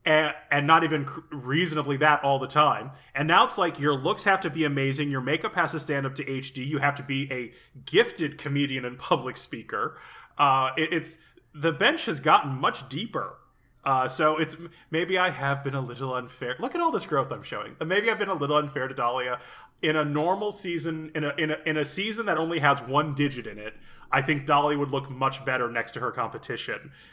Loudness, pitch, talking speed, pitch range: -26 LUFS, 150 Hz, 220 wpm, 135-160 Hz